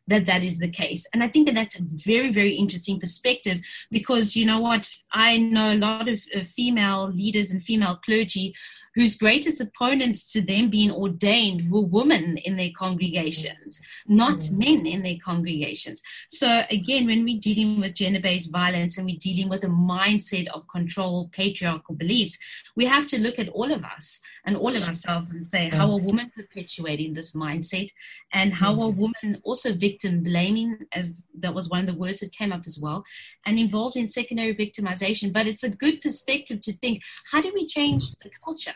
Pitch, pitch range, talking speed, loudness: 200 Hz, 180-225 Hz, 190 wpm, -23 LUFS